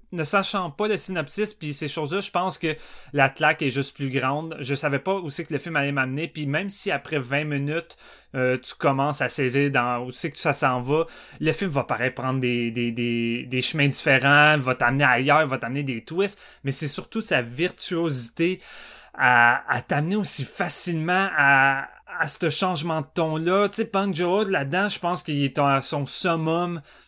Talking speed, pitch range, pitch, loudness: 205 wpm, 135-175 Hz, 150 Hz, -23 LUFS